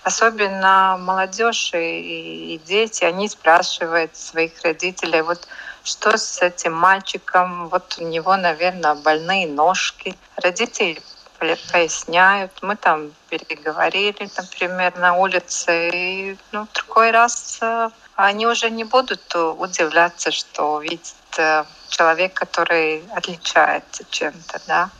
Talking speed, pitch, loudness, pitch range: 105 wpm, 180 Hz, -19 LUFS, 165-200 Hz